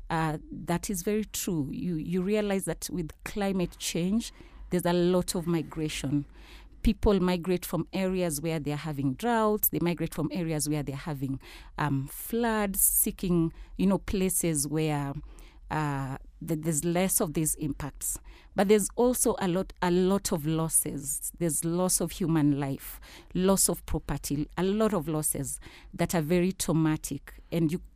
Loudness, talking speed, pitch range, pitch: -28 LUFS, 160 wpm, 155-190 Hz, 170 Hz